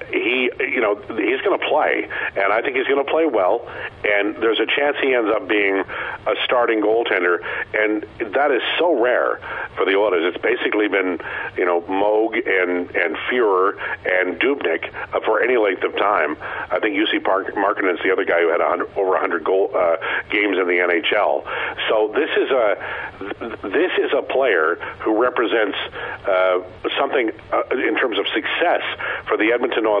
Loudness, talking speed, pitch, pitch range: -19 LUFS, 185 wpm, 105 Hz, 95-125 Hz